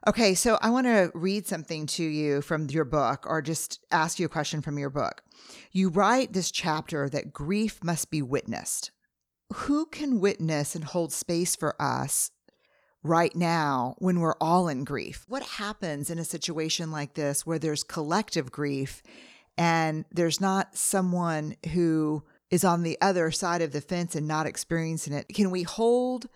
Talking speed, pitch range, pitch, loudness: 175 wpm, 155-190 Hz, 165 Hz, -28 LUFS